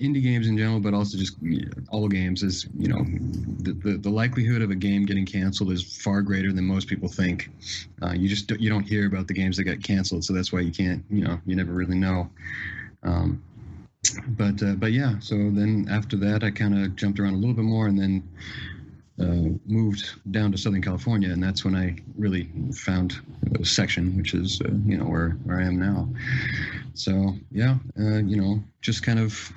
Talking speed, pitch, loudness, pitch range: 210 wpm, 100 Hz, -25 LUFS, 95-110 Hz